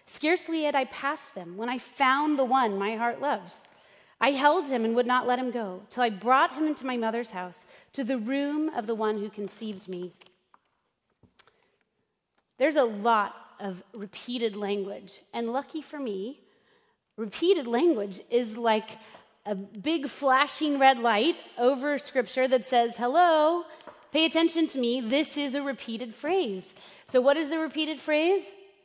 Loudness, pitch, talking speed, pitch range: -27 LUFS, 255 Hz, 160 wpm, 225-300 Hz